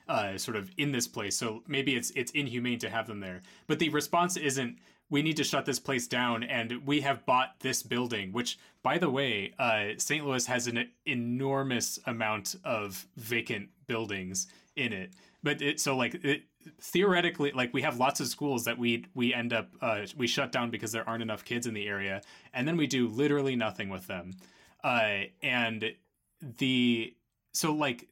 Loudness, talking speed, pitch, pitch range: -31 LUFS, 190 wpm, 125 Hz, 115-140 Hz